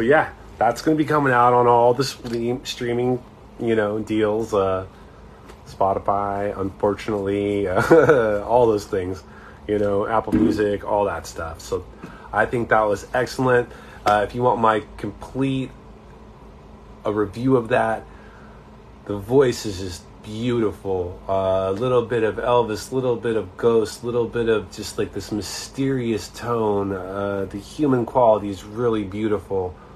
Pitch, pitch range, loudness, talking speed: 110 Hz, 100-120 Hz, -21 LUFS, 155 wpm